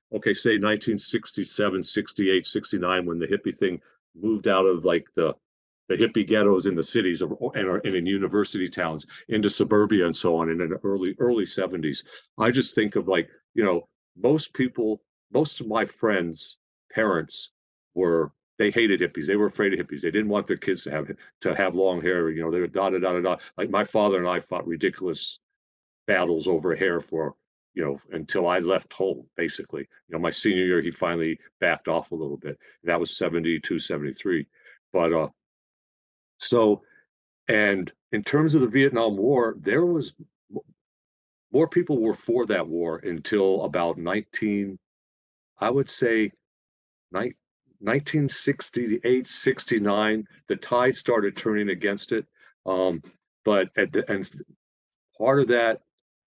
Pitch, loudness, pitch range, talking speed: 100 Hz, -25 LUFS, 90-115 Hz, 165 wpm